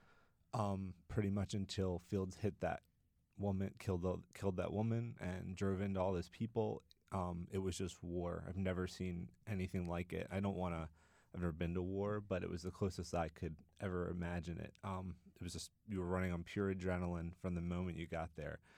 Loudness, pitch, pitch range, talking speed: -43 LUFS, 90 Hz, 85-100 Hz, 210 wpm